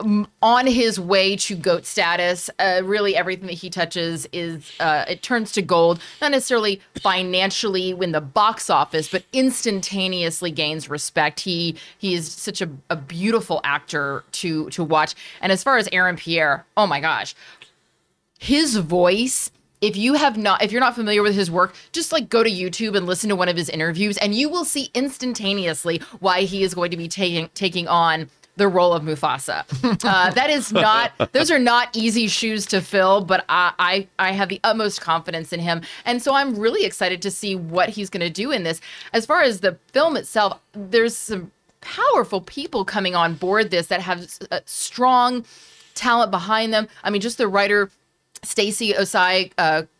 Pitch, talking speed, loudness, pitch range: 195 Hz, 185 wpm, -20 LUFS, 175-220 Hz